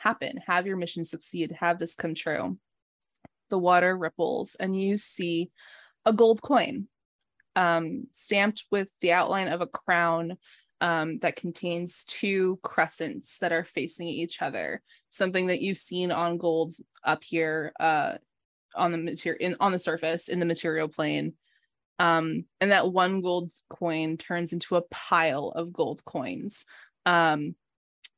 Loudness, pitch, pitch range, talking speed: -27 LUFS, 175 Hz, 165-185 Hz, 145 wpm